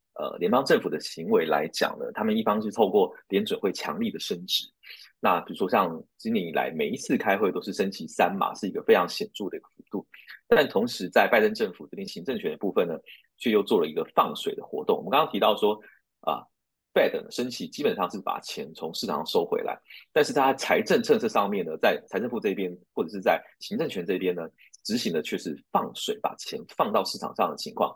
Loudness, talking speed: -27 LUFS, 335 characters per minute